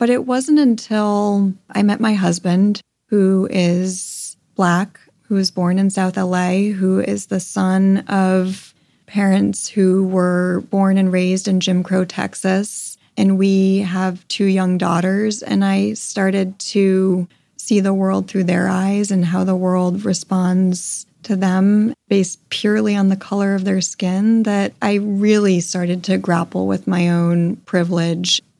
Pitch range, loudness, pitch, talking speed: 180-200 Hz, -17 LUFS, 190 Hz, 155 wpm